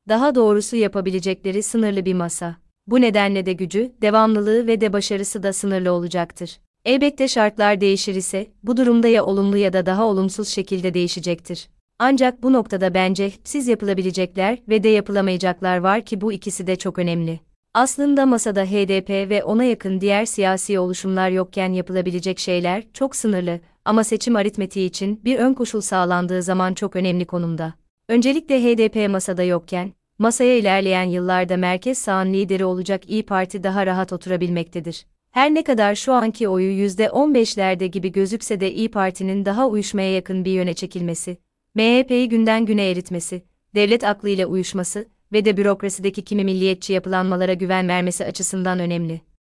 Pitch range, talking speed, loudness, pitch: 185-220 Hz, 150 wpm, -20 LUFS, 195 Hz